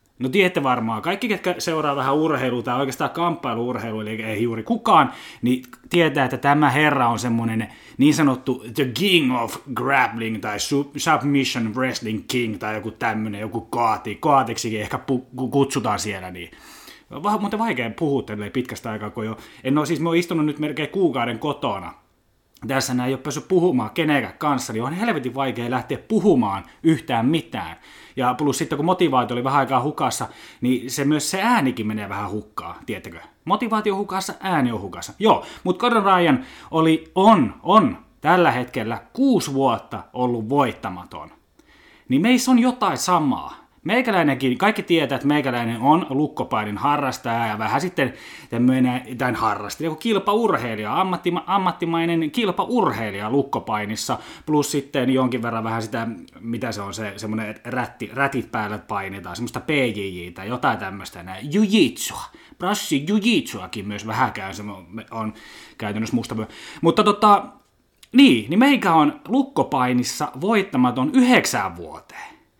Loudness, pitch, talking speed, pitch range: -21 LUFS, 130 Hz, 150 wpm, 115-165 Hz